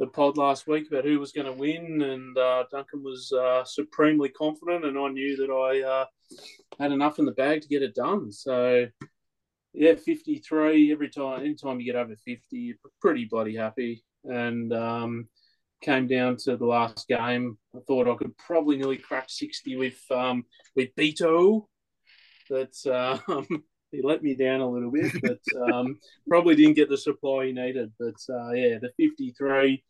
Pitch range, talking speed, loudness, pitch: 125-150 Hz, 180 wpm, -26 LUFS, 135 Hz